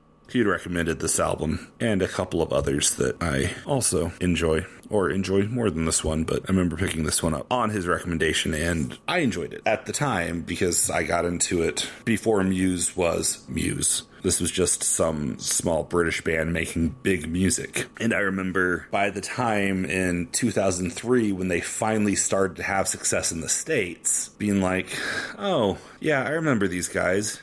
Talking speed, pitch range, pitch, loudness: 175 wpm, 85-95 Hz, 90 Hz, -24 LUFS